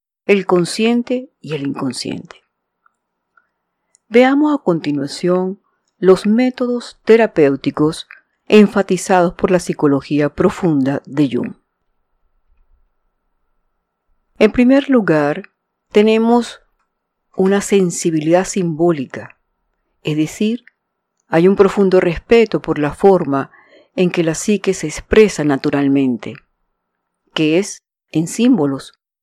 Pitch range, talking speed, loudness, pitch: 150-215 Hz, 90 wpm, -15 LUFS, 185 Hz